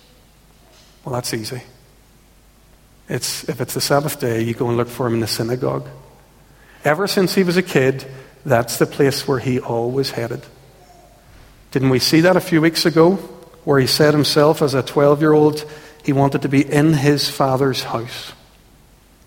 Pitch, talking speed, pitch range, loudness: 135 Hz, 175 wpm, 125-155 Hz, -17 LUFS